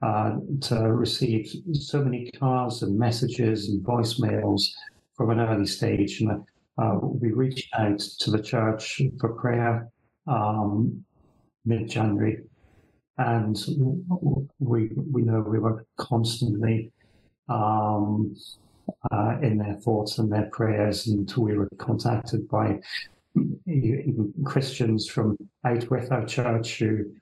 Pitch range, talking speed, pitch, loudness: 105-125 Hz, 115 wpm, 115 Hz, -26 LUFS